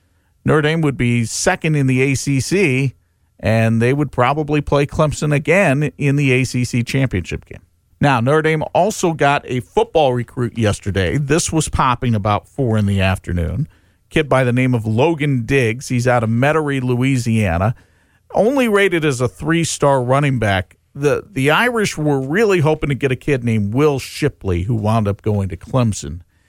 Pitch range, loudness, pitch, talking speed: 110-145 Hz, -17 LUFS, 130 Hz, 170 wpm